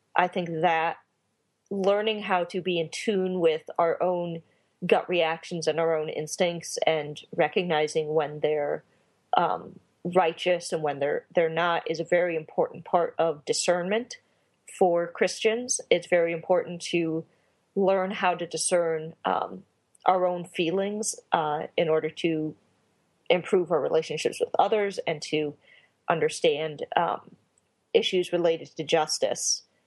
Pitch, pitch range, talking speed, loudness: 175 Hz, 160-190 Hz, 135 wpm, -27 LUFS